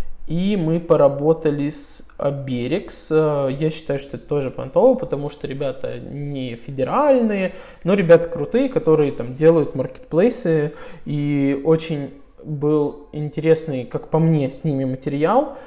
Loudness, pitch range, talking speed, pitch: -20 LUFS, 140-165 Hz, 125 wpm, 150 Hz